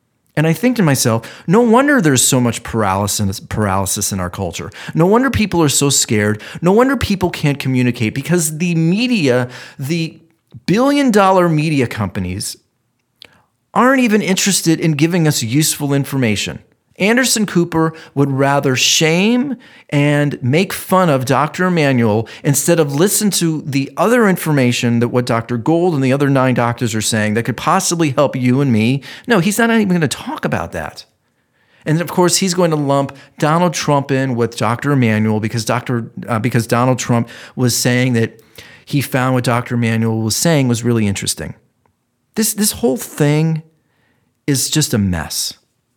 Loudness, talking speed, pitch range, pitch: -15 LUFS, 165 wpm, 120-170 Hz, 140 Hz